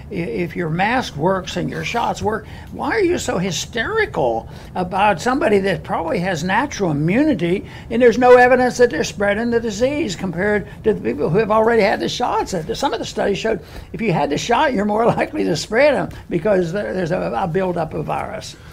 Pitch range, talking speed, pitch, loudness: 185-245 Hz, 195 wpm, 210 Hz, -18 LUFS